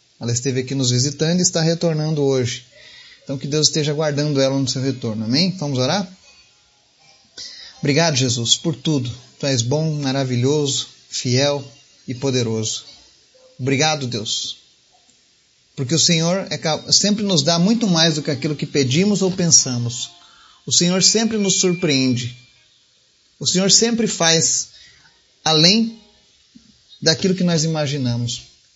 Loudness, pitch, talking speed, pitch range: -18 LUFS, 145 Hz, 135 wpm, 130-170 Hz